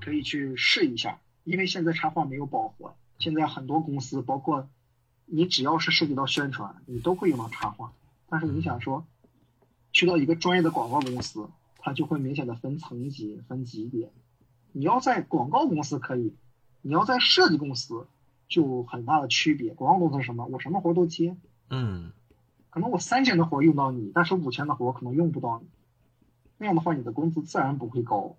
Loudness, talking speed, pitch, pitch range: -26 LUFS, 295 characters per minute, 140 Hz, 125-160 Hz